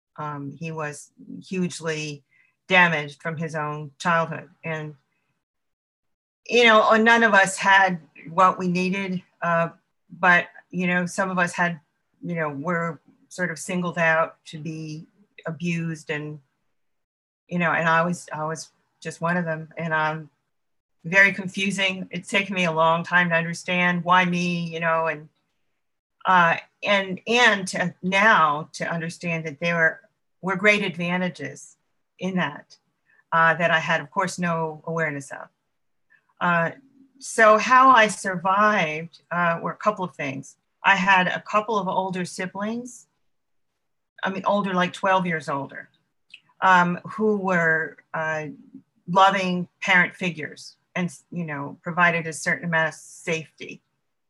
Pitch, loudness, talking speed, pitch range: 175 Hz, -22 LUFS, 145 wpm, 160-190 Hz